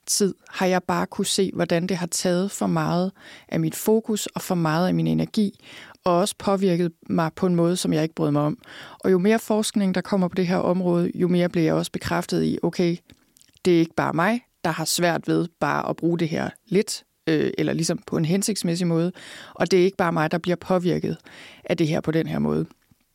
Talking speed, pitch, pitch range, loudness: 235 wpm, 175 Hz, 165-190 Hz, -23 LUFS